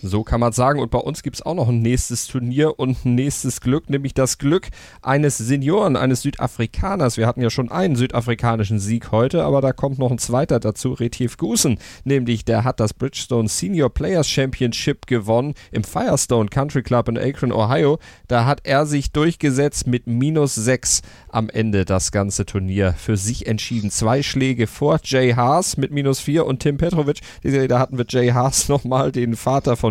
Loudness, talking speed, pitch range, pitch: -19 LUFS, 190 wpm, 115-140 Hz, 125 Hz